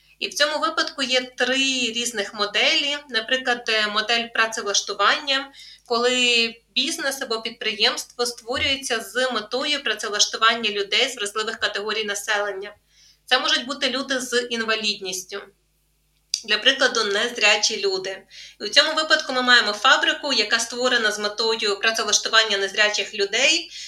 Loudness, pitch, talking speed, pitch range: -20 LUFS, 230 Hz, 120 wpm, 210-265 Hz